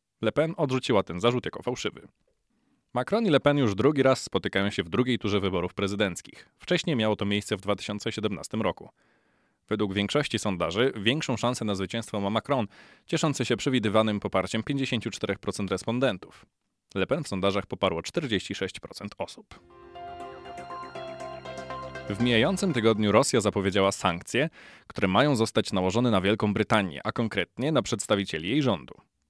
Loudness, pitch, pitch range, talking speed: -27 LUFS, 110 Hz, 100-130 Hz, 140 wpm